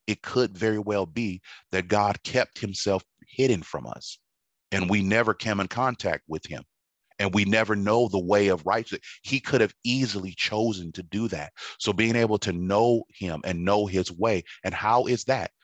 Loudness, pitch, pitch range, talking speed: -26 LUFS, 105 Hz, 95-115 Hz, 190 wpm